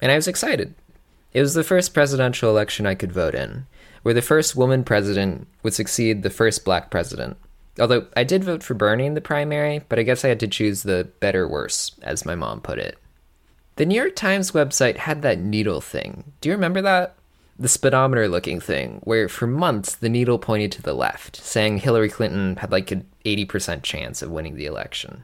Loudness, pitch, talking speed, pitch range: -21 LUFS, 115 Hz, 200 wpm, 100-145 Hz